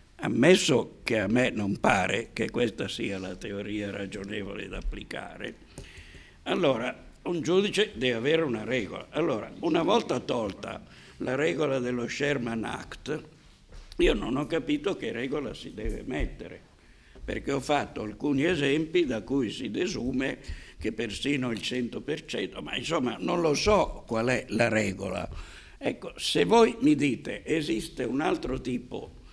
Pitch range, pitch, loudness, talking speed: 100-145 Hz, 125 Hz, -28 LUFS, 145 wpm